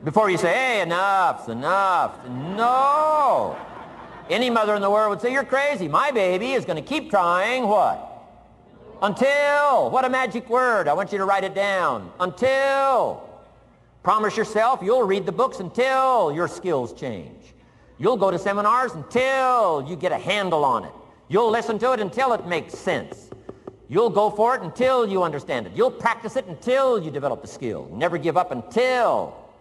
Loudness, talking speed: -21 LUFS, 175 wpm